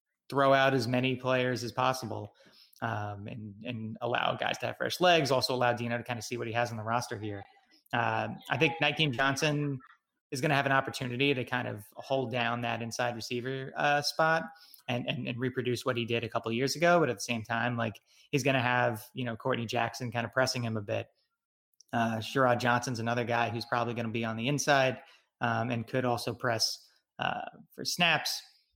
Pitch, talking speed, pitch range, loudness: 120 Hz, 215 wpm, 115-135 Hz, -30 LUFS